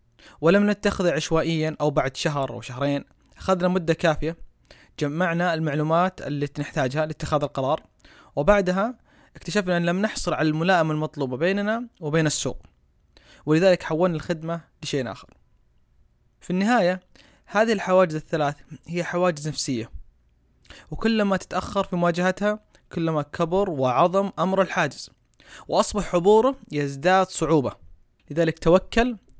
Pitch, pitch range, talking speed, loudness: 165 Hz, 145-185 Hz, 115 wpm, -23 LUFS